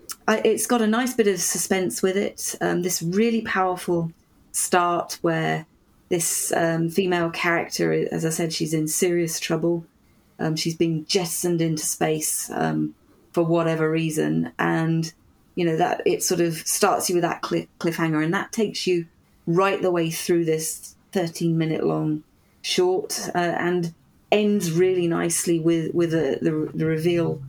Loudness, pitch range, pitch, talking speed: -23 LUFS, 160-180 Hz, 170 Hz, 155 wpm